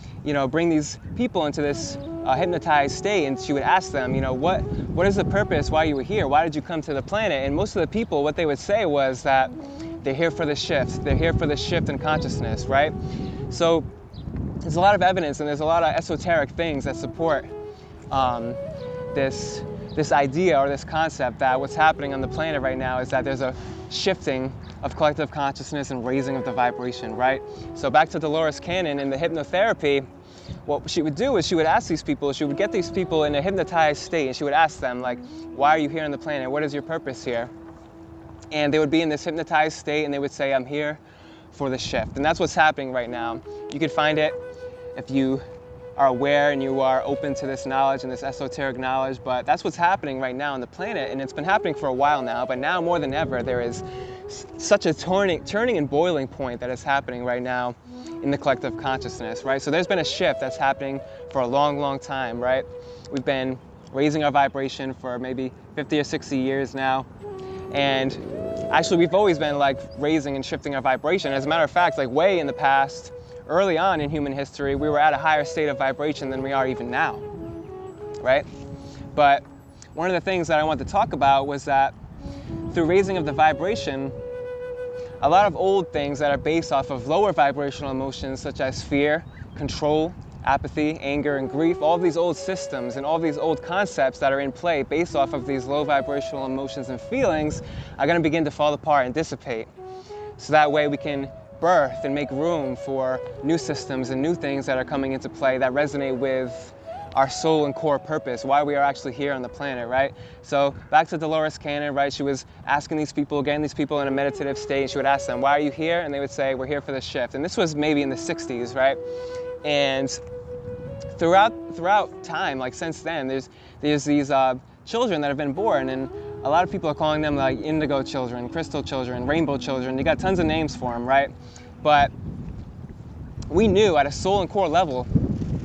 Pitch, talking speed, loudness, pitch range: 140 Hz, 220 wpm, -23 LUFS, 130-155 Hz